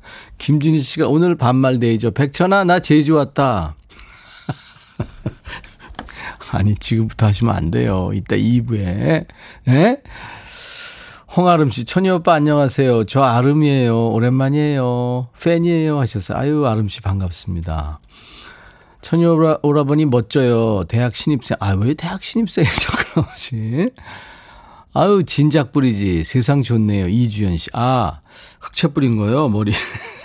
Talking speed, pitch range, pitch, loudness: 260 characters per minute, 110-155 Hz, 130 Hz, -17 LUFS